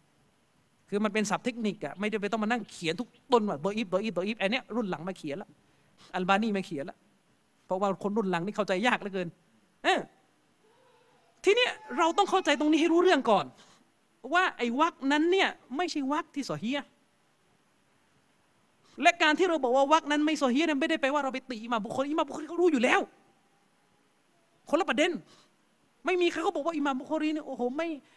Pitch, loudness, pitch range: 265 Hz, -28 LUFS, 205-320 Hz